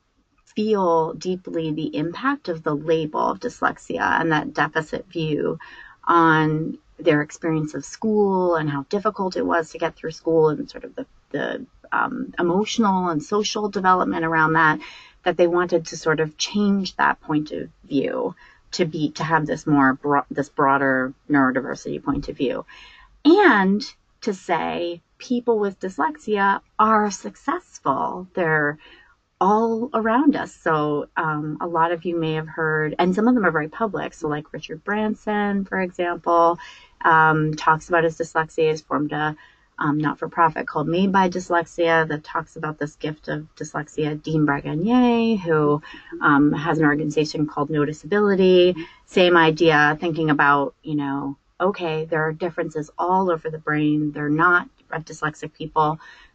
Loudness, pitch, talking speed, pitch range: -21 LUFS, 160 Hz, 155 wpm, 155-190 Hz